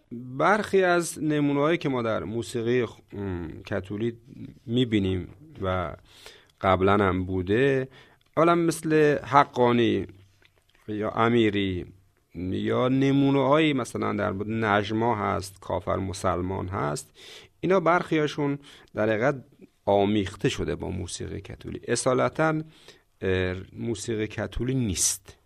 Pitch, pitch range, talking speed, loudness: 115 Hz, 100-140 Hz, 95 wpm, -25 LUFS